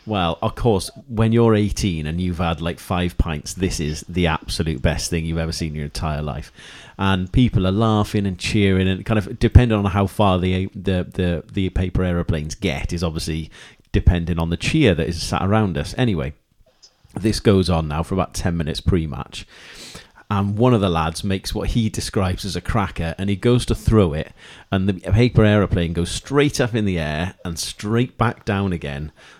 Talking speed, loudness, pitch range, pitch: 205 wpm, -20 LUFS, 85-105 Hz, 95 Hz